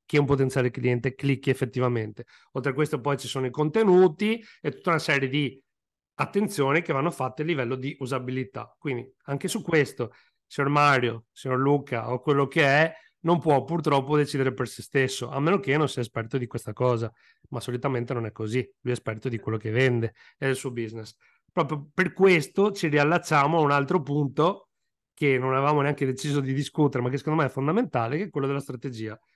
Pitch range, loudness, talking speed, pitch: 125-150 Hz, -25 LUFS, 200 wpm, 140 Hz